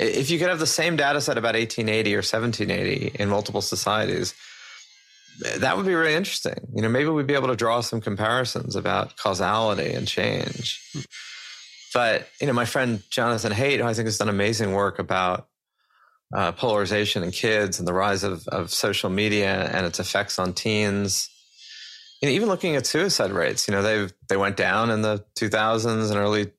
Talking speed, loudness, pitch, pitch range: 190 wpm, -23 LUFS, 110 Hz, 100-115 Hz